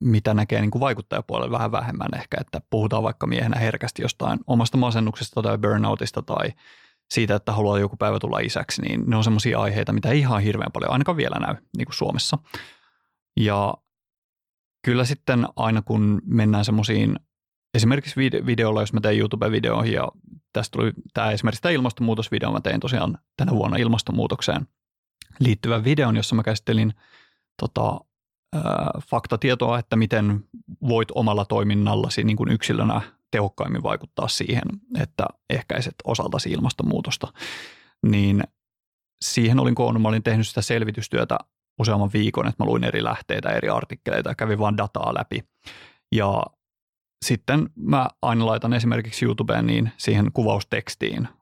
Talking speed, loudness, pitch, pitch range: 140 wpm, -23 LUFS, 110 Hz, 105-120 Hz